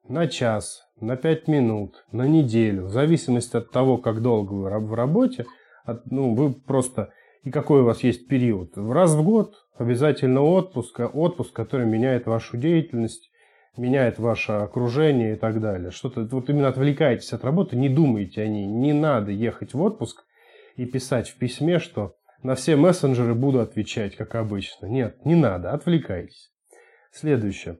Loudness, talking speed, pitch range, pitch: -23 LUFS, 160 wpm, 115-150 Hz, 125 Hz